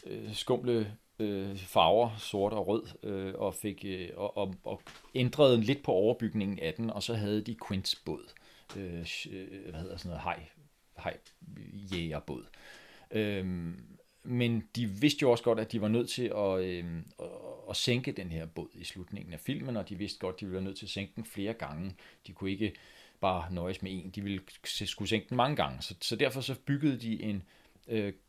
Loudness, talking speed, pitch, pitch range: -34 LUFS, 200 wpm, 100 Hz, 95-115 Hz